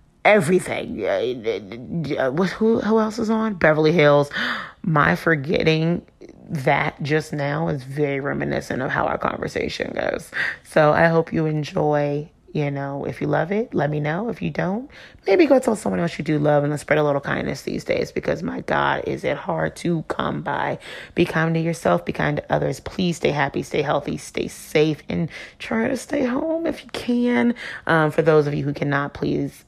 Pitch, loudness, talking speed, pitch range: 160 Hz, -21 LUFS, 195 wpm, 145-210 Hz